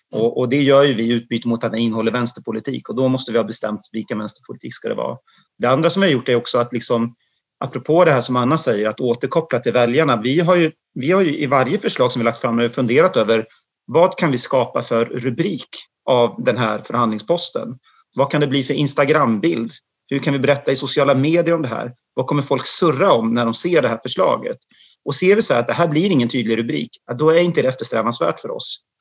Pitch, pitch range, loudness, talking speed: 125 Hz, 115-145 Hz, -18 LUFS, 235 wpm